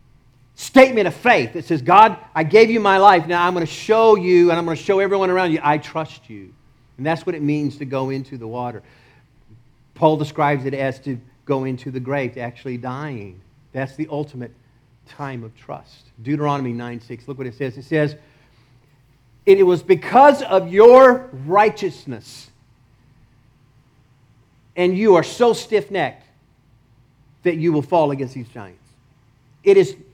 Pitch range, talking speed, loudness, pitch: 125-170 Hz, 165 wpm, -16 LUFS, 140 Hz